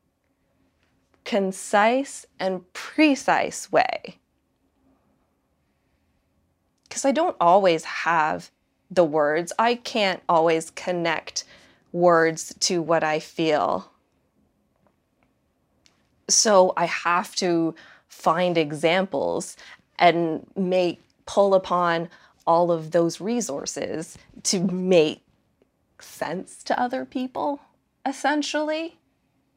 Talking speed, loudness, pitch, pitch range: 85 wpm, -23 LUFS, 175 Hz, 155-200 Hz